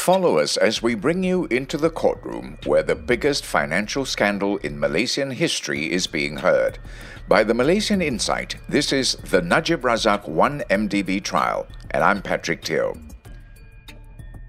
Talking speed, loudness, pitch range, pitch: 145 wpm, -21 LUFS, 110-165 Hz, 120 Hz